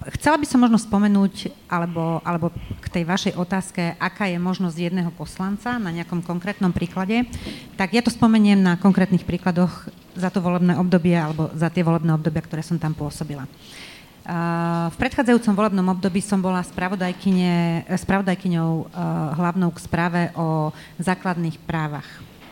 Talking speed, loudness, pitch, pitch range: 140 wpm, -22 LUFS, 180 Hz, 170-195 Hz